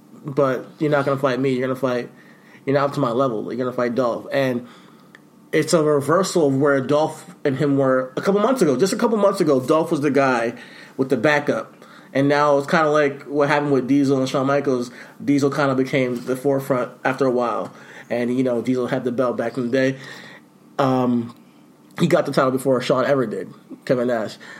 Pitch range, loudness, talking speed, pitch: 130-145 Hz, -20 LUFS, 215 wpm, 135 Hz